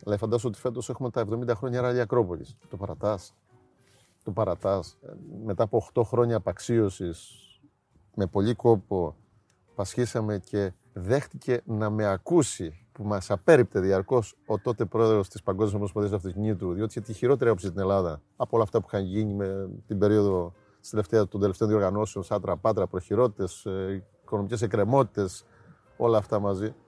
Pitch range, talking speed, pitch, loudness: 100-115 Hz, 150 wpm, 105 Hz, -27 LUFS